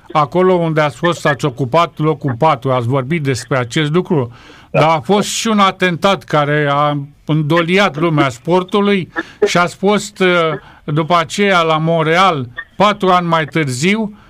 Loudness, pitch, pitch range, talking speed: -14 LUFS, 165 Hz, 150-185 Hz, 145 wpm